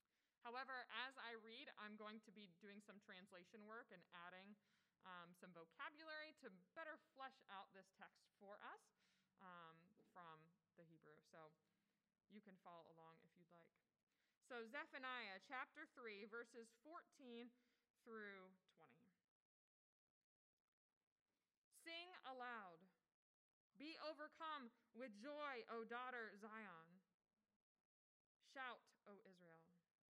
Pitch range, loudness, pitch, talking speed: 185-245 Hz, -58 LUFS, 215 Hz, 115 wpm